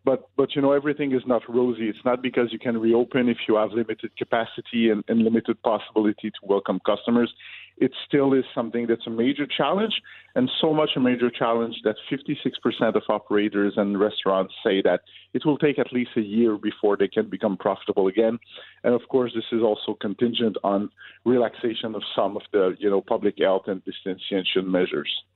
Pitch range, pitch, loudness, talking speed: 105-125 Hz, 115 Hz, -24 LUFS, 190 wpm